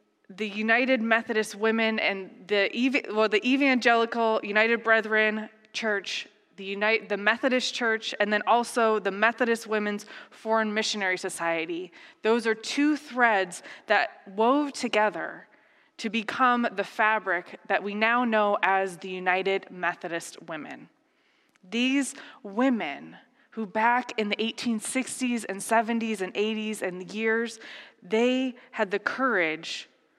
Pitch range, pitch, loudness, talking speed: 205-235 Hz, 220 Hz, -26 LUFS, 125 wpm